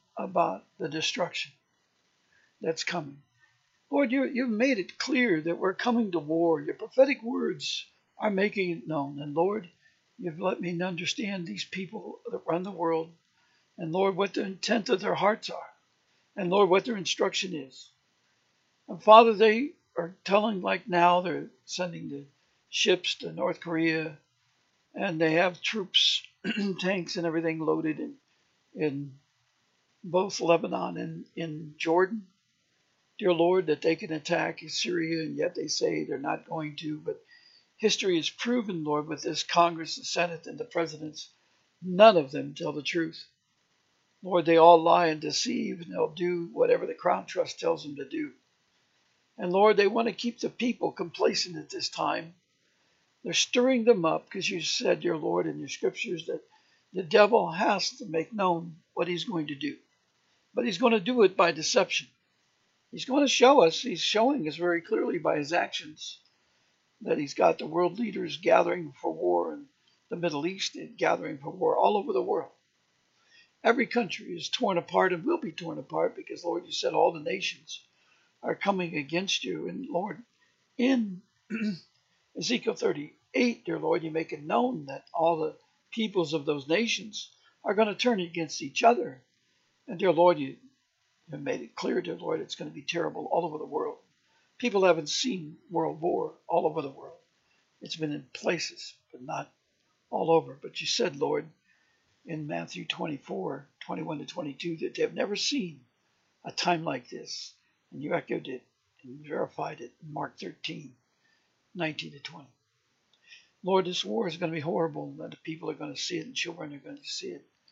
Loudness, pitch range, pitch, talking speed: -28 LUFS, 165-235 Hz, 180 Hz, 175 wpm